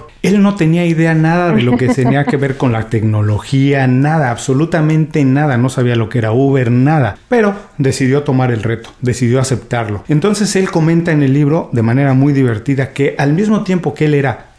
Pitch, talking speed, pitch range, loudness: 140 Hz, 195 wpm, 125-160 Hz, -13 LUFS